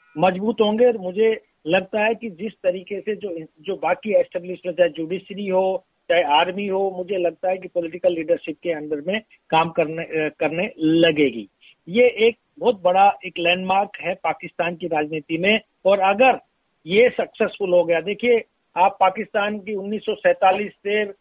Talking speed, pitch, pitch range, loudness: 160 wpm, 185 Hz, 170-210 Hz, -21 LUFS